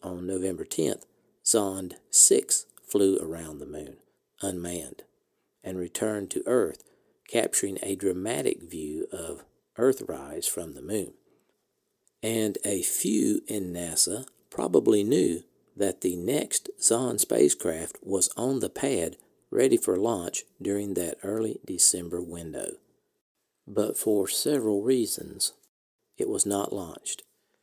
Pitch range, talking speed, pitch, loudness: 90-145 Hz, 120 wpm, 100 Hz, -27 LUFS